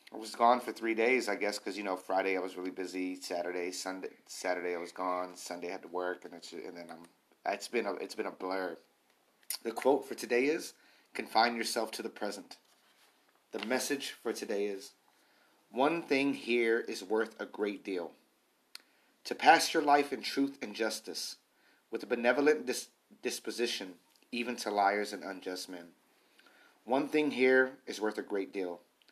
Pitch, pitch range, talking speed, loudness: 105 Hz, 90-120 Hz, 185 wpm, -33 LUFS